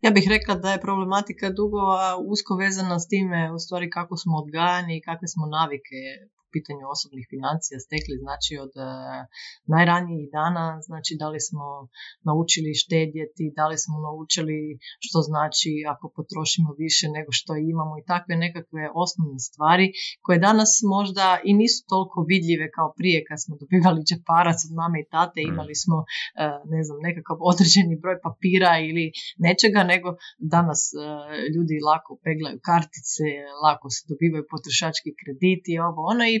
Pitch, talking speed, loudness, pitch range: 160 Hz, 155 wpm, -23 LUFS, 155-180 Hz